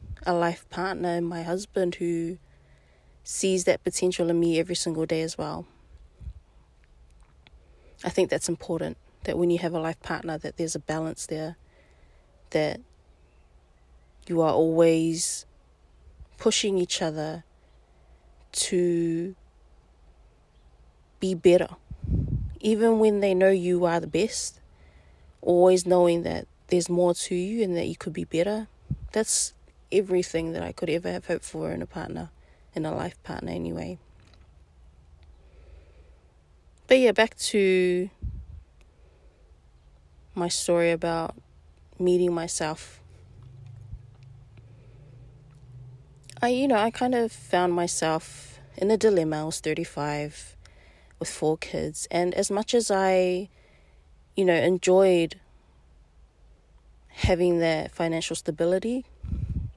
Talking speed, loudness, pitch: 120 wpm, -26 LUFS, 150 Hz